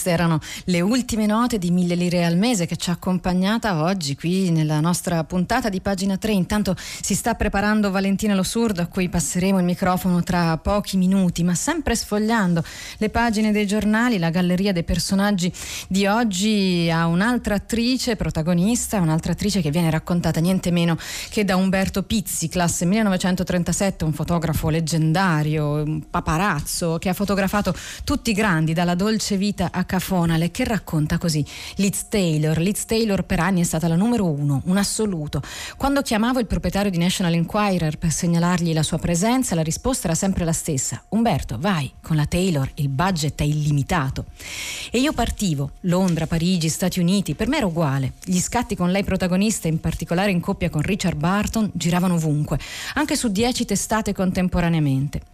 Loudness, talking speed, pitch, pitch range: -21 LUFS, 165 wpm, 180 Hz, 165-205 Hz